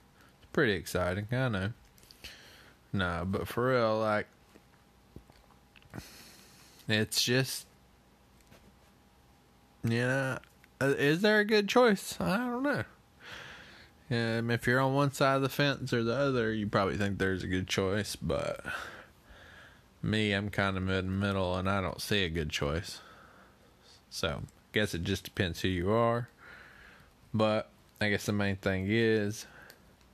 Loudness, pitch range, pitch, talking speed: -31 LUFS, 90-125 Hz, 105 Hz, 145 wpm